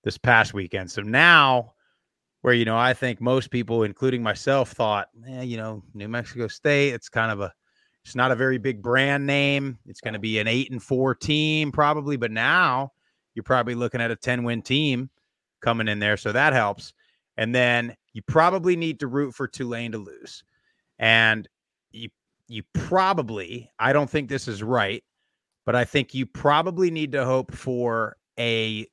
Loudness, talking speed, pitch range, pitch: -22 LUFS, 185 wpm, 115-135 Hz, 125 Hz